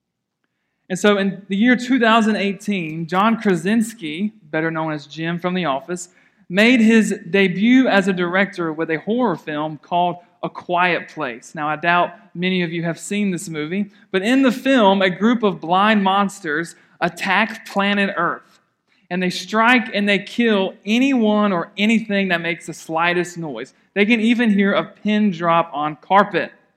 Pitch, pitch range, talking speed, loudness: 195 Hz, 170-210 Hz, 165 wpm, -18 LUFS